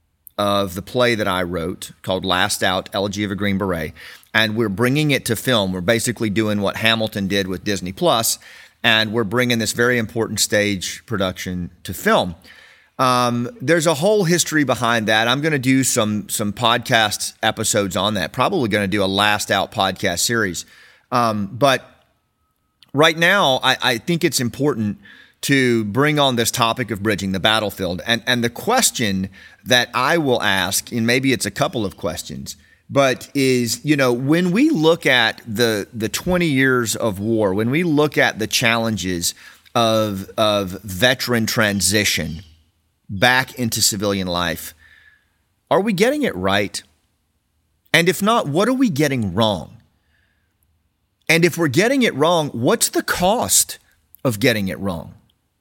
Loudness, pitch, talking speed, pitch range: -18 LUFS, 110 Hz, 165 wpm, 100-125 Hz